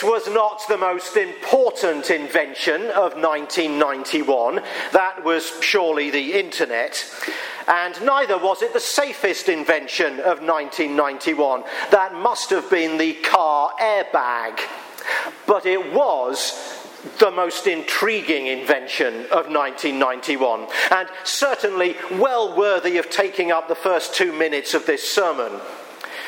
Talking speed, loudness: 120 wpm, -20 LUFS